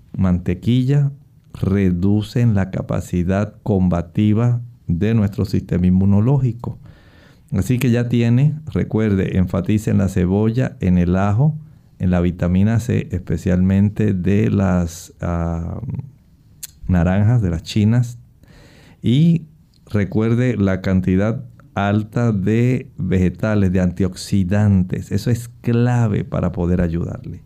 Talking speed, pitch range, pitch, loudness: 105 wpm, 90-120 Hz, 100 Hz, -18 LUFS